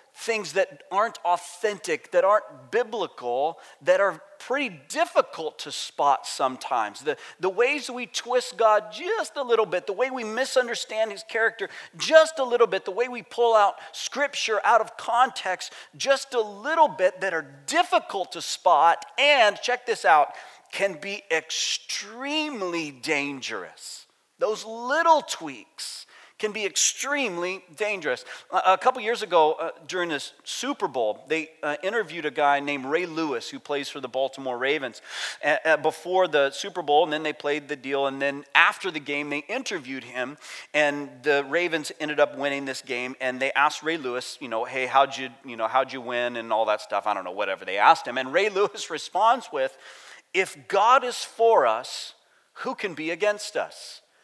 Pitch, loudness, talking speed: 195 Hz, -25 LUFS, 170 wpm